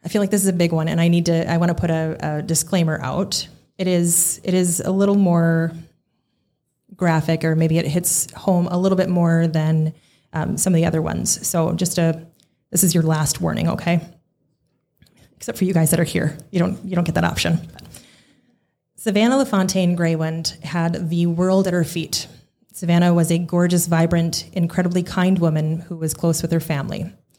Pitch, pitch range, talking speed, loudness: 170 Hz, 165-185 Hz, 195 wpm, -19 LUFS